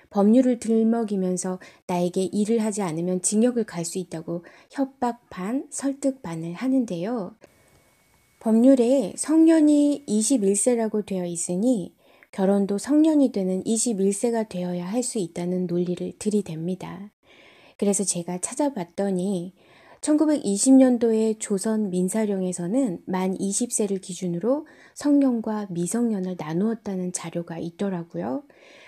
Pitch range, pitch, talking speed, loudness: 180-245 Hz, 205 Hz, 260 characters per minute, -24 LUFS